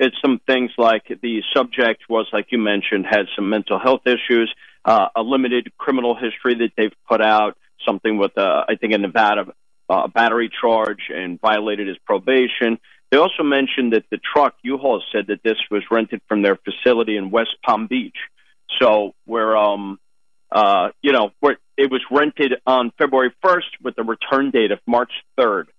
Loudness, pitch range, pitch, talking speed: -18 LUFS, 105-125 Hz, 115 Hz, 180 wpm